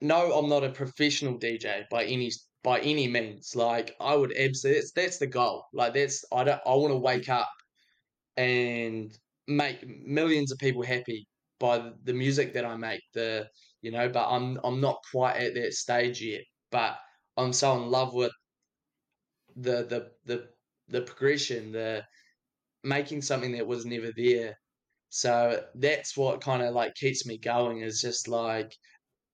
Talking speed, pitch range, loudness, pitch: 170 wpm, 120-135 Hz, -29 LUFS, 125 Hz